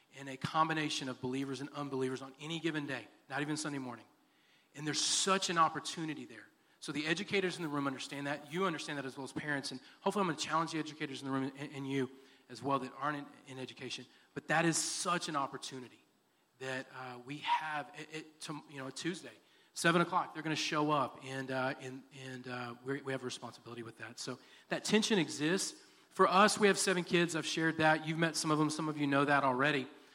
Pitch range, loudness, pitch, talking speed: 135-160 Hz, -35 LUFS, 145 Hz, 230 wpm